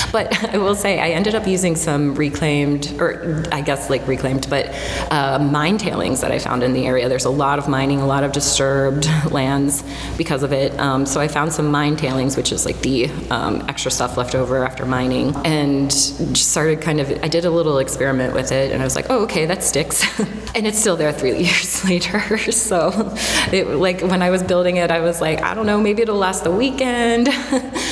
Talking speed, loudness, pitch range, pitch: 220 wpm, -18 LUFS, 140-185 Hz, 150 Hz